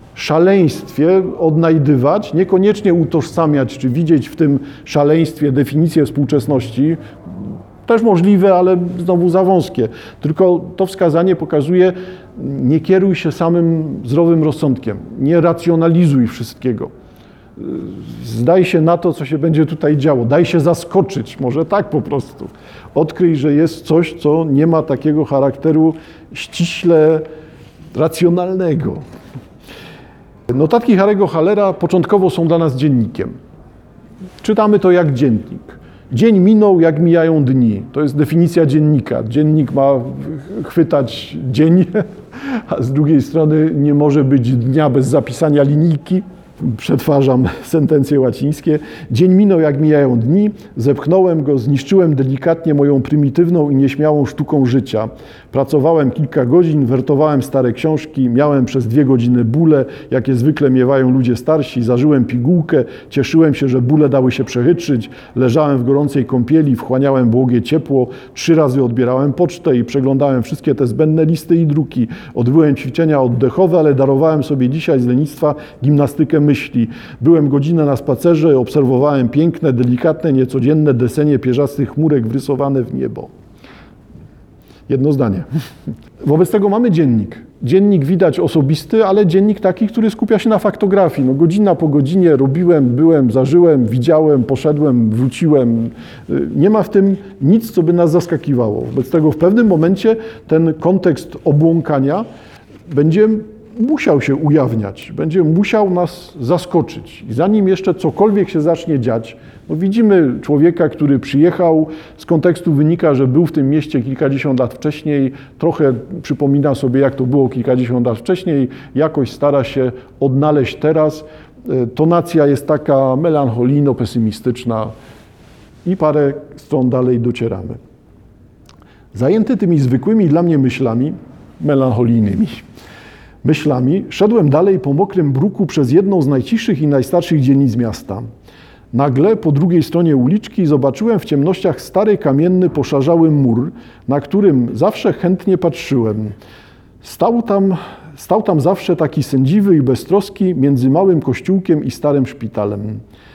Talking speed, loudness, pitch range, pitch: 130 wpm, -13 LUFS, 130-170 Hz, 150 Hz